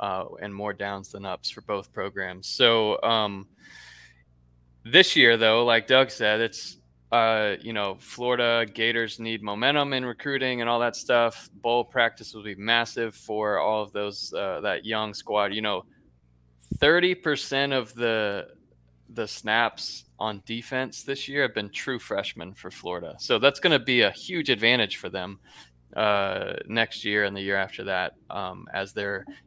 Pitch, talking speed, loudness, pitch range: 110 Hz, 170 wpm, -25 LUFS, 100-115 Hz